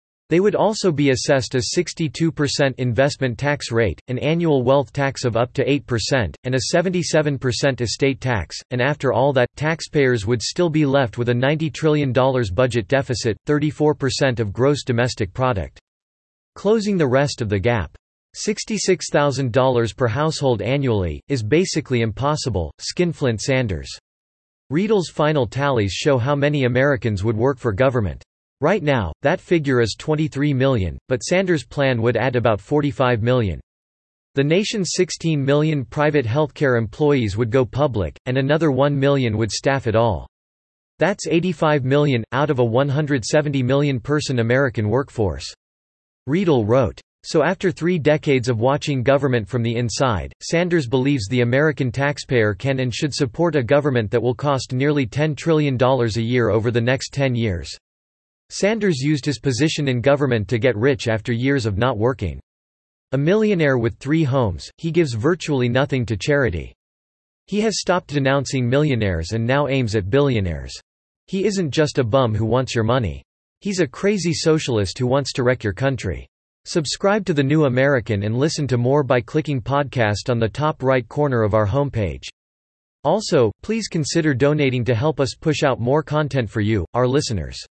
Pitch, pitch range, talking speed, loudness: 135 Hz, 115-150 Hz, 165 wpm, -20 LUFS